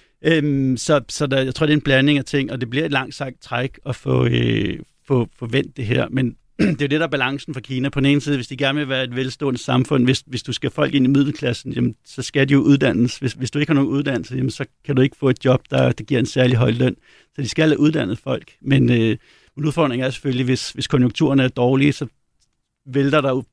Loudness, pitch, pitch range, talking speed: -19 LUFS, 135 Hz, 125-145 Hz, 270 wpm